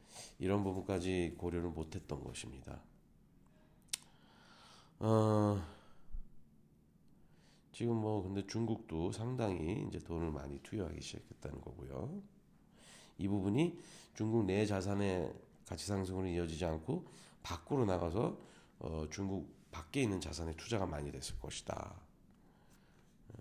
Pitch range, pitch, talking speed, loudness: 85-110 Hz, 95 Hz, 240 characters per minute, -39 LUFS